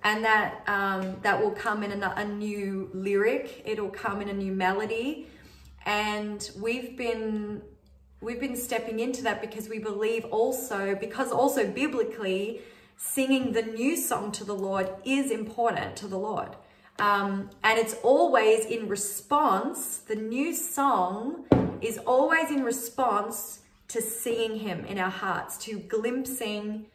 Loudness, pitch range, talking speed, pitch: -28 LUFS, 205-240 Hz, 145 wpm, 220 Hz